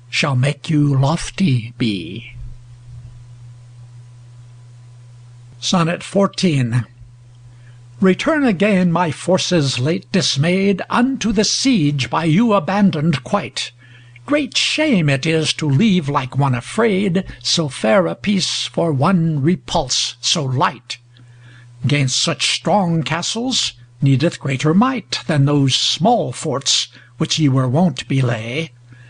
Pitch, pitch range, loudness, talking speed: 145 Hz, 120-180 Hz, -17 LUFS, 110 wpm